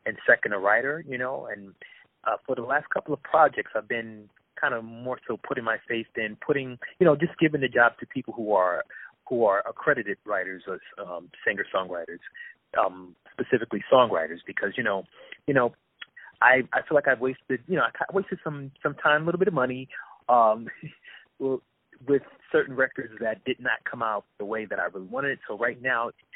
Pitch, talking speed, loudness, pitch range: 130 Hz, 200 wpm, -26 LUFS, 115-145 Hz